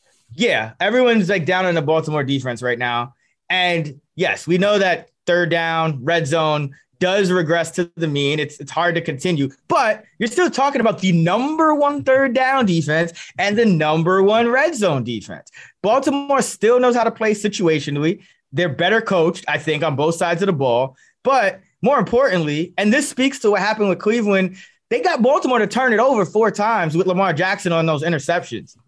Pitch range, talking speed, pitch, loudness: 160-225 Hz, 190 wpm, 185 Hz, -18 LUFS